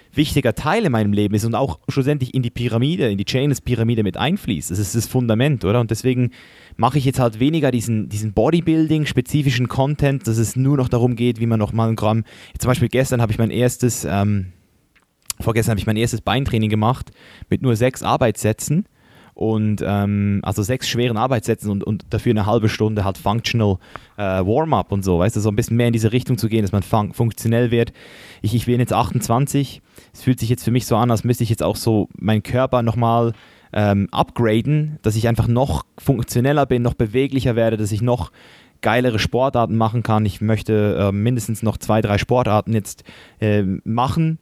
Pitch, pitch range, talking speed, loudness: 115 Hz, 110-125 Hz, 200 wpm, -19 LUFS